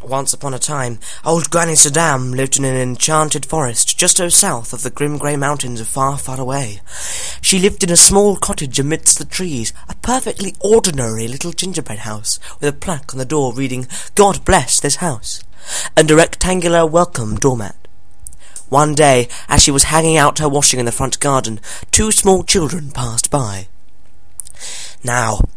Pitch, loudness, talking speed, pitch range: 140 Hz, -14 LUFS, 170 wpm, 120-165 Hz